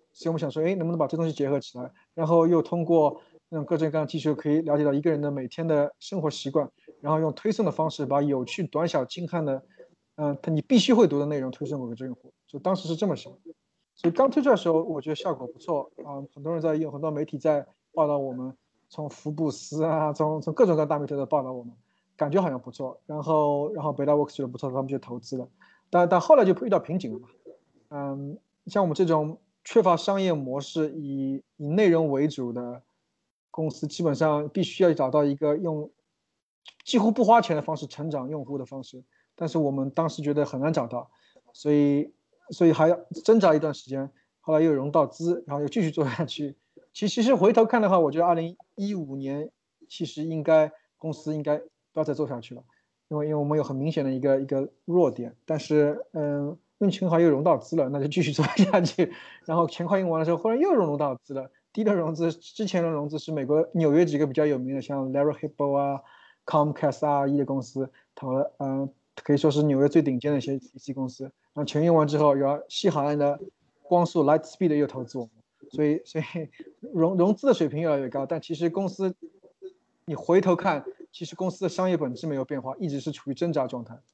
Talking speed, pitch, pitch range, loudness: 345 characters per minute, 155 Hz, 140-170 Hz, -25 LUFS